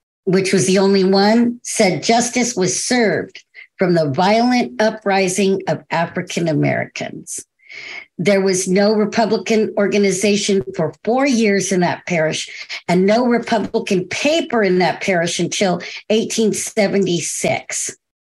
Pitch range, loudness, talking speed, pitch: 185-225 Hz, -17 LUFS, 120 wpm, 200 Hz